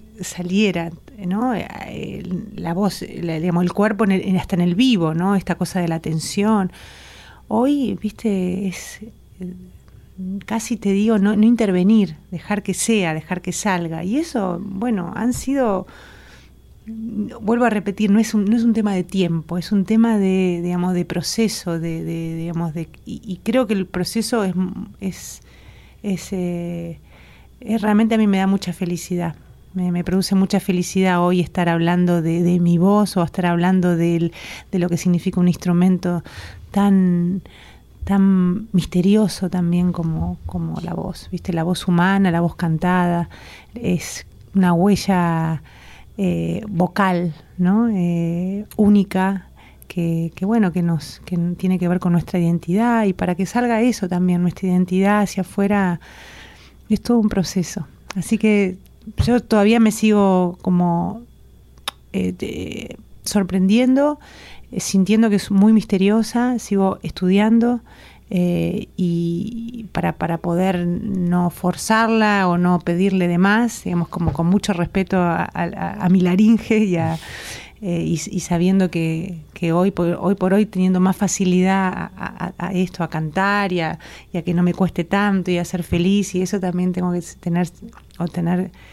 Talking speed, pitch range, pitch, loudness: 160 wpm, 175-205 Hz, 185 Hz, -19 LUFS